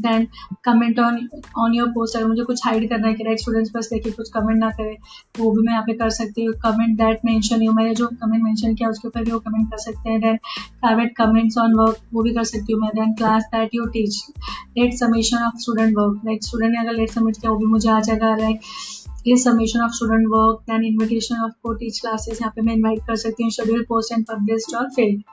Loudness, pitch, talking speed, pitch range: -20 LUFS, 225 Hz, 115 wpm, 220-230 Hz